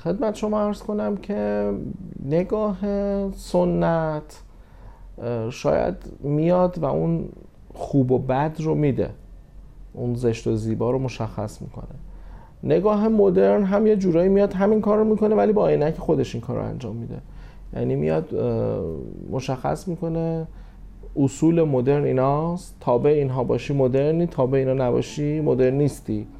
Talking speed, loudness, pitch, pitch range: 135 wpm, -22 LUFS, 145 Hz, 120-180 Hz